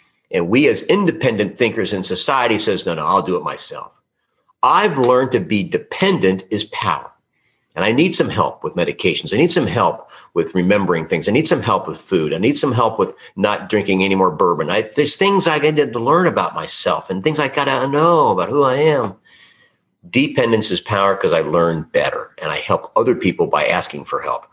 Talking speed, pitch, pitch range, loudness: 210 wpm, 130 Hz, 100-155 Hz, -16 LUFS